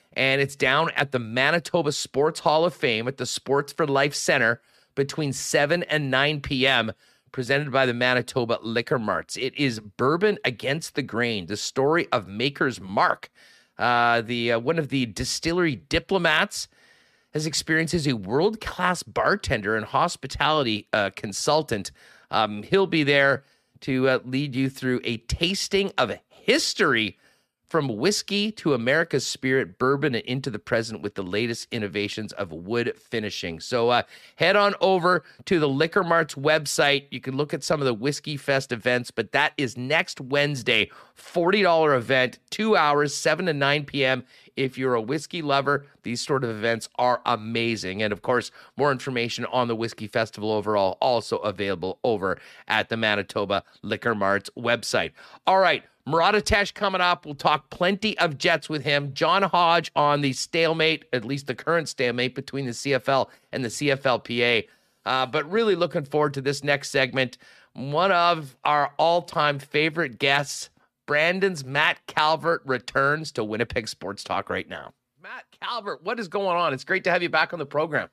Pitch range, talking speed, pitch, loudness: 125-160 Hz, 170 wpm, 140 Hz, -24 LUFS